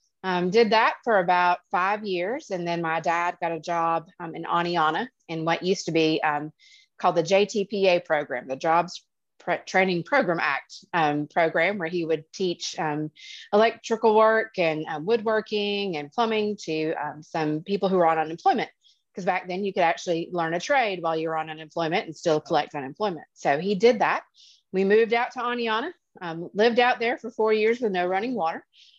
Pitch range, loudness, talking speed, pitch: 160-215 Hz, -25 LUFS, 195 wpm, 180 Hz